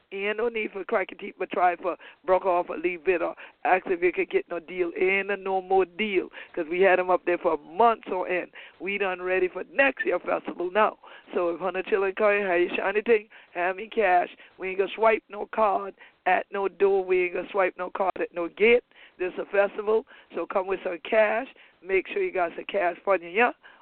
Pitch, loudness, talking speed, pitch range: 195 Hz, -26 LUFS, 245 wpm, 180-235 Hz